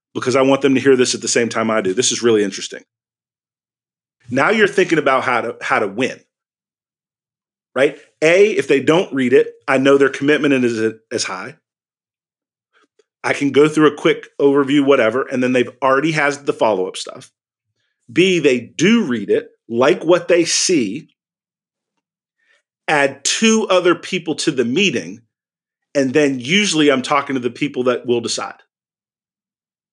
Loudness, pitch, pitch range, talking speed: -16 LUFS, 140 Hz, 125-175 Hz, 170 wpm